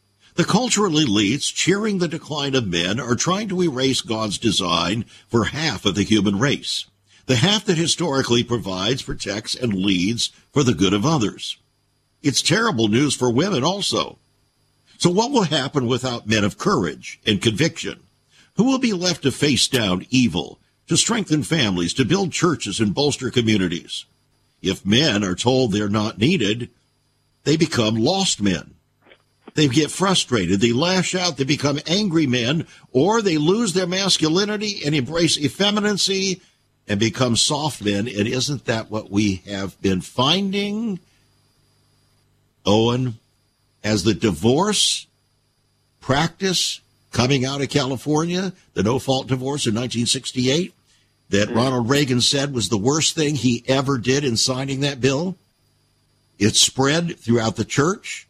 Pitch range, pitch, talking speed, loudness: 110-160 Hz, 130 Hz, 145 wpm, -20 LUFS